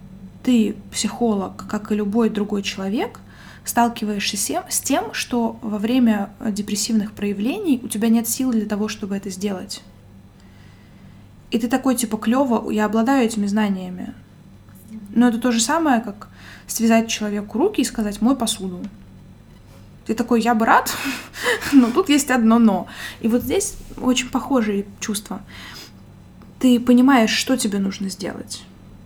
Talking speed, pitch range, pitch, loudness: 140 wpm, 205-245 Hz, 220 Hz, -20 LUFS